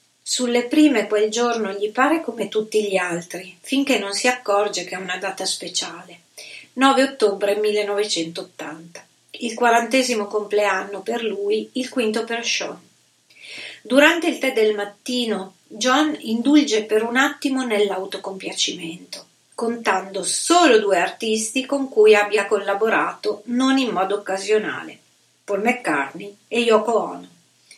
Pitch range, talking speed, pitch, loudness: 200-250 Hz, 125 wpm, 215 Hz, -20 LUFS